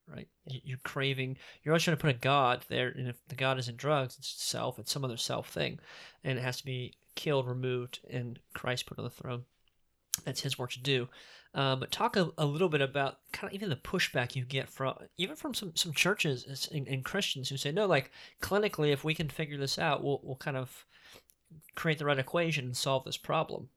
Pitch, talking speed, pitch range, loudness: 135 Hz, 225 wpm, 130-160 Hz, -33 LUFS